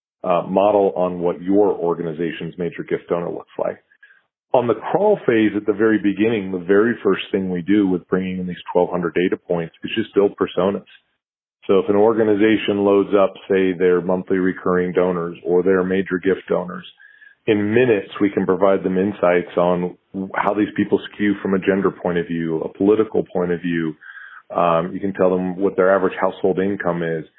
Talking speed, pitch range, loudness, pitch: 190 wpm, 90-100 Hz, -19 LUFS, 95 Hz